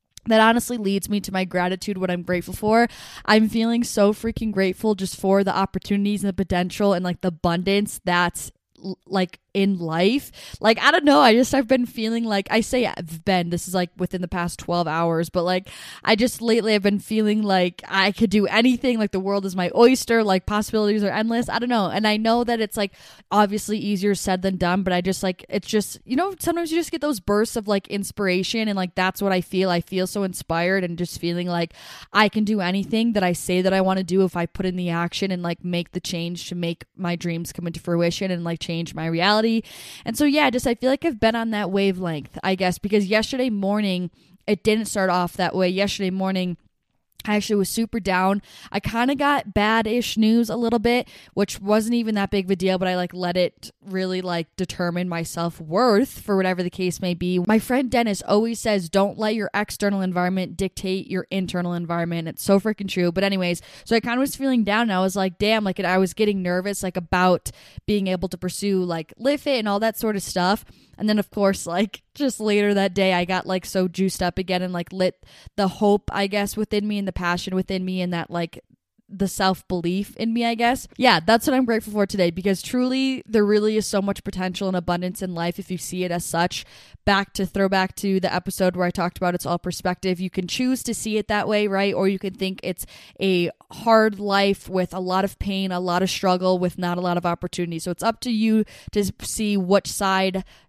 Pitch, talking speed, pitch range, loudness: 195 Hz, 235 wpm, 180-215 Hz, -22 LUFS